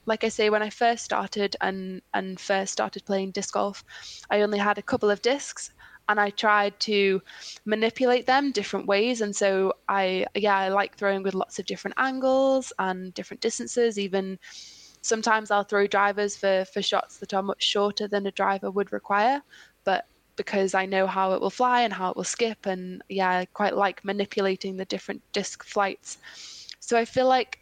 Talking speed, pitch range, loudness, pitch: 190 wpm, 195-220 Hz, -26 LUFS, 205 Hz